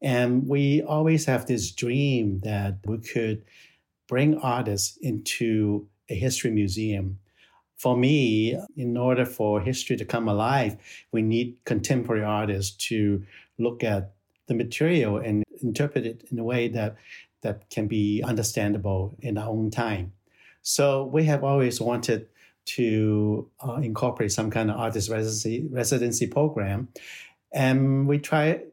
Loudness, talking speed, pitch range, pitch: -26 LUFS, 140 wpm, 105-130 Hz, 115 Hz